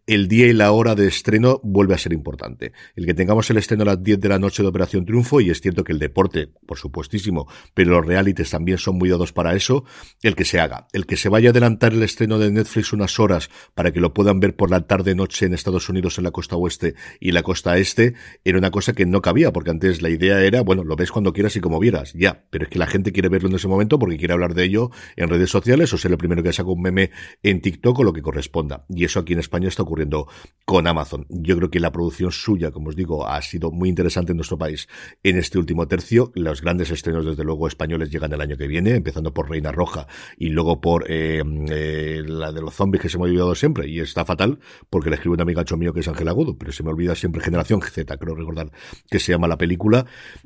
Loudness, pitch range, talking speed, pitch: -20 LUFS, 80-100 Hz, 255 wpm, 90 Hz